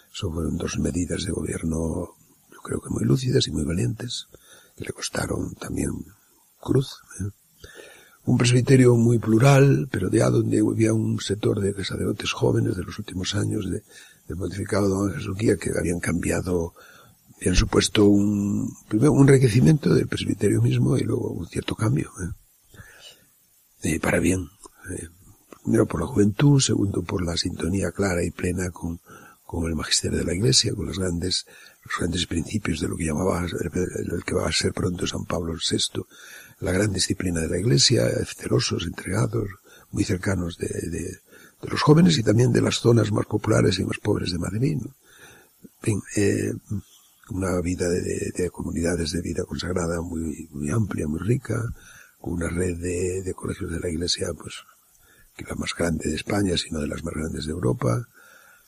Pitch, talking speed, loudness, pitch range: 95 Hz, 175 wpm, -23 LUFS, 85-110 Hz